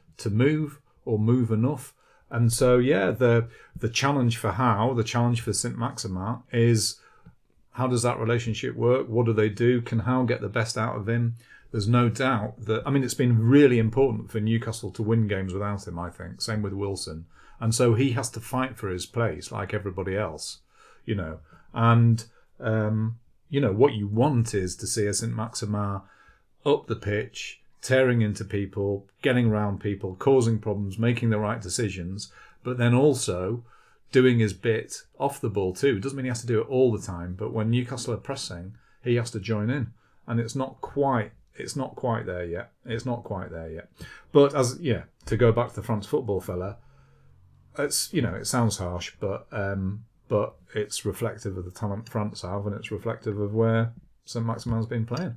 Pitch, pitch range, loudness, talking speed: 115 Hz, 105-120 Hz, -26 LUFS, 195 wpm